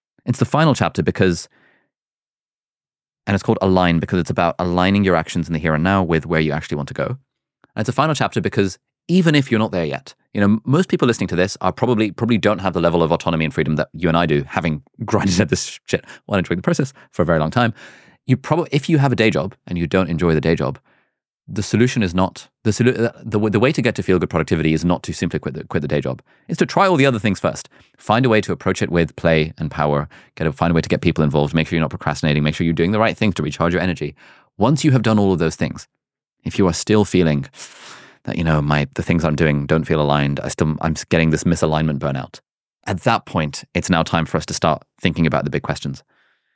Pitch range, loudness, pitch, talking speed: 80-110 Hz, -18 LUFS, 90 Hz, 265 wpm